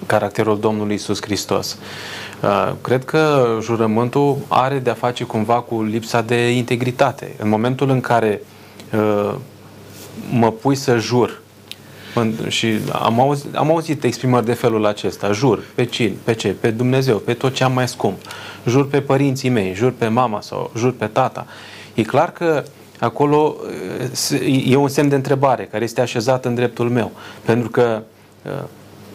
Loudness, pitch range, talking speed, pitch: -18 LUFS, 110-130 Hz, 160 wpm, 120 Hz